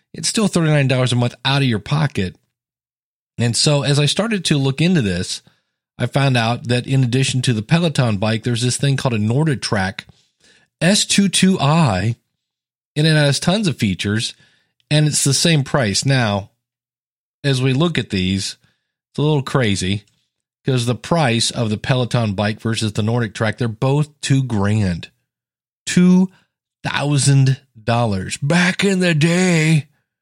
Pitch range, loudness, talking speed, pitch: 115-150 Hz, -17 LUFS, 155 wpm, 135 Hz